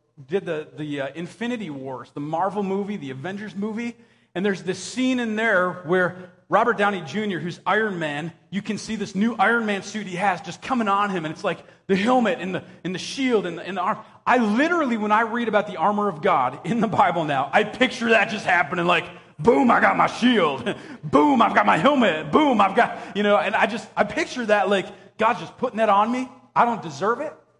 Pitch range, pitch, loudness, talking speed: 180-230 Hz, 205 Hz, -22 LUFS, 230 wpm